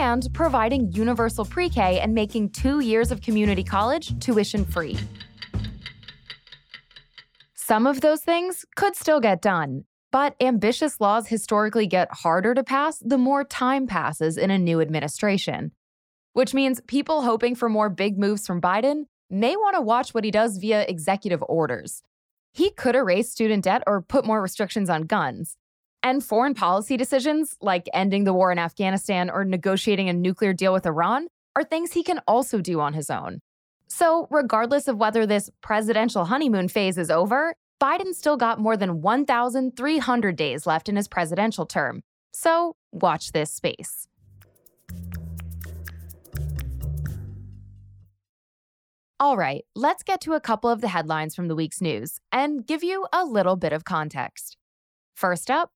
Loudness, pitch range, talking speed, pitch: -23 LUFS, 170-260 Hz, 155 wpm, 210 Hz